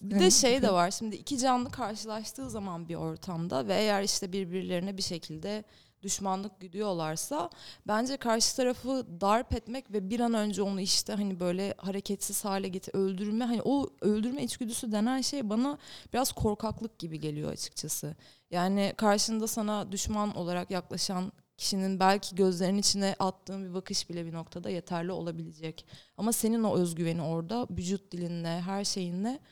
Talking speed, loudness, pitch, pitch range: 155 wpm, -31 LUFS, 195 Hz, 180-220 Hz